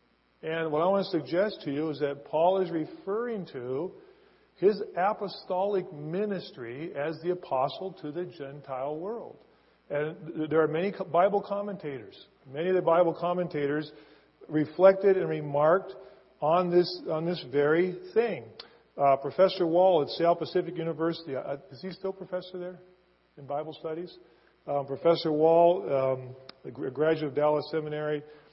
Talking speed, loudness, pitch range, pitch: 145 wpm, -28 LUFS, 150-185 Hz, 165 Hz